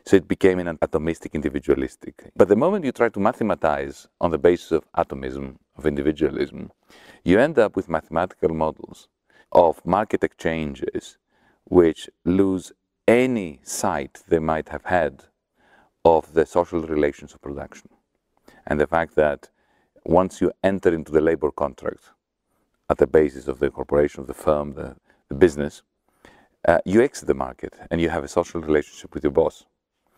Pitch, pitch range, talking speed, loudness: 85 Hz, 75-90 Hz, 160 wpm, -22 LUFS